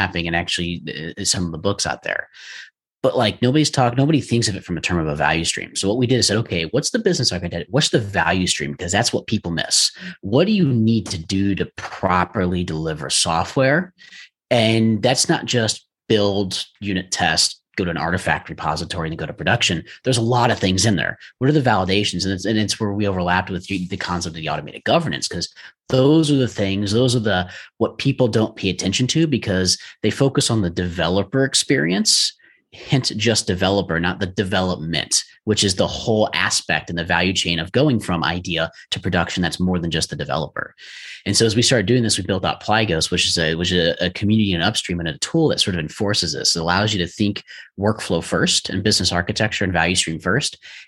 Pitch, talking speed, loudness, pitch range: 100 Hz, 215 wpm, -19 LUFS, 90-115 Hz